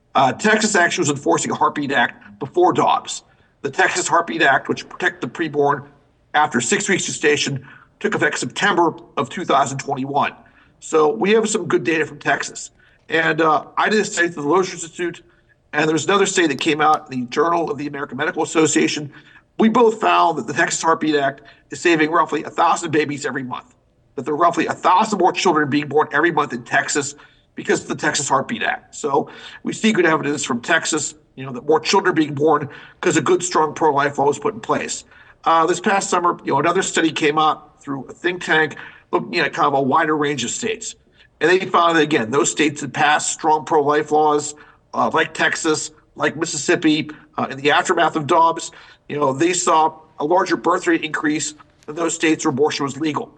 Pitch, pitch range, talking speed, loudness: 155 Hz, 145-175 Hz, 210 wpm, -18 LUFS